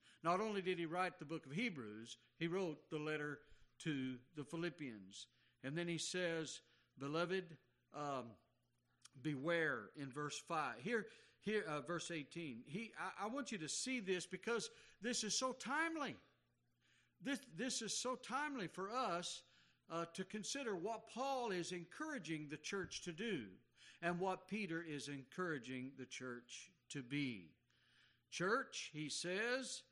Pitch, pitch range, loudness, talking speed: 170 Hz, 140-210 Hz, -45 LUFS, 150 wpm